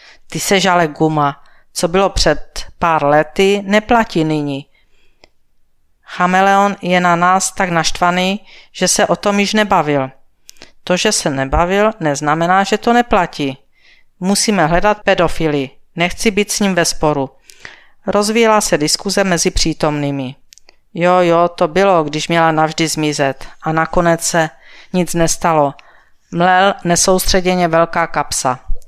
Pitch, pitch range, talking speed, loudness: 175 Hz, 155-195 Hz, 130 wpm, -14 LUFS